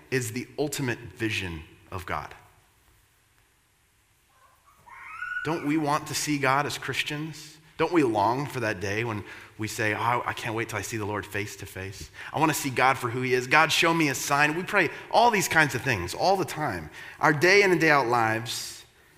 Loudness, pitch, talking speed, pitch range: -25 LUFS, 125 Hz, 205 wpm, 110-150 Hz